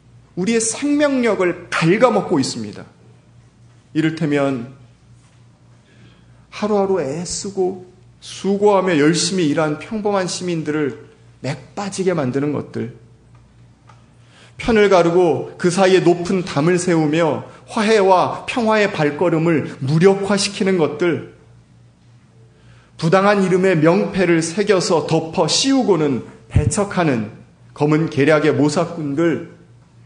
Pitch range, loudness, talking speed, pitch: 130-190 Hz, -17 LUFS, 230 characters per minute, 165 Hz